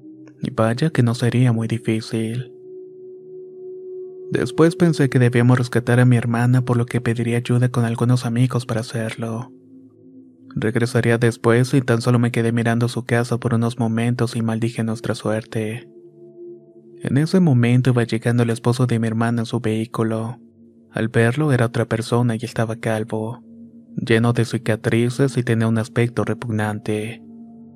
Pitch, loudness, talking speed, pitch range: 120 Hz, -20 LUFS, 150 wpm, 115-130 Hz